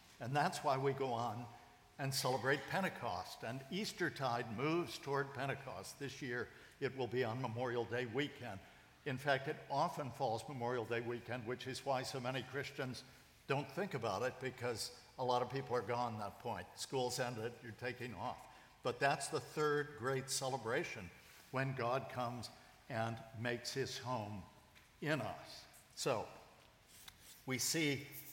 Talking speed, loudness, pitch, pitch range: 160 wpm, -41 LUFS, 130 Hz, 120-140 Hz